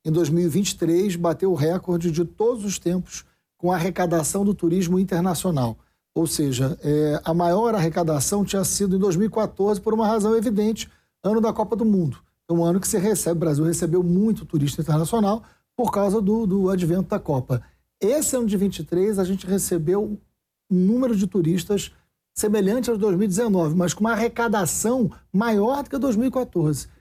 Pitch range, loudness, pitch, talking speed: 170-215 Hz, -22 LUFS, 190 Hz, 165 wpm